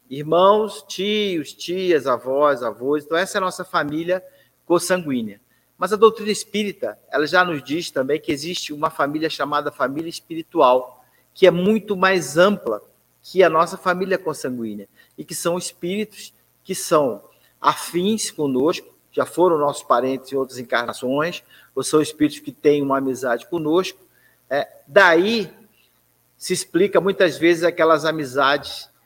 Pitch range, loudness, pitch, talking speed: 140-185 Hz, -20 LUFS, 165 Hz, 140 wpm